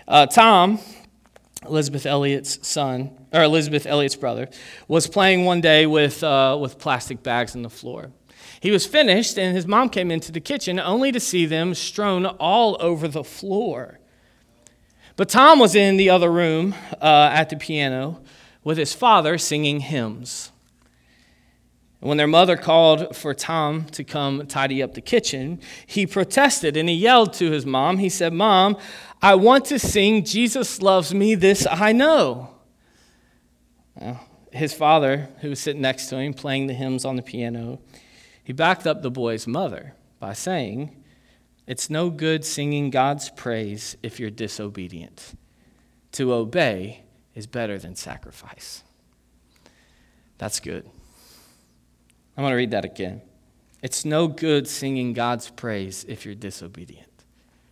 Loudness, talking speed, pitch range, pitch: -19 LUFS, 150 wpm, 125-180 Hz, 145 Hz